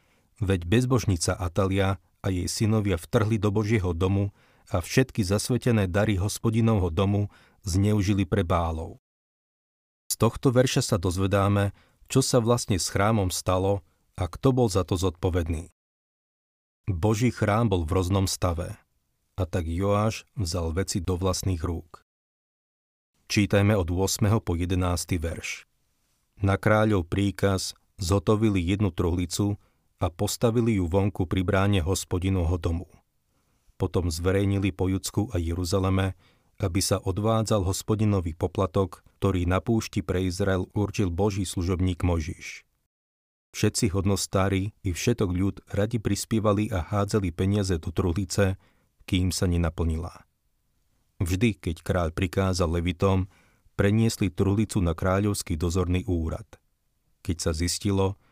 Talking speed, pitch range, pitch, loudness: 120 wpm, 90-105 Hz, 95 Hz, -26 LUFS